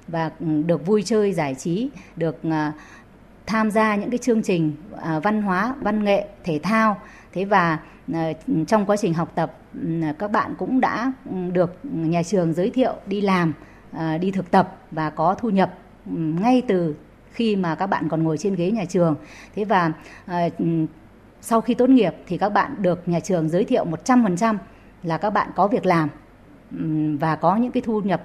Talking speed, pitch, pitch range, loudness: 175 wpm, 185 Hz, 160-215 Hz, -22 LUFS